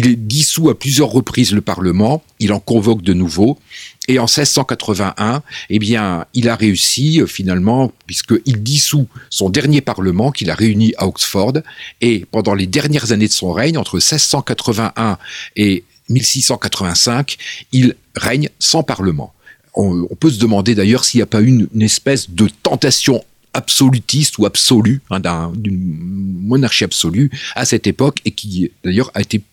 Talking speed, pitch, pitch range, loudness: 160 wpm, 115 Hz, 100-130 Hz, -14 LUFS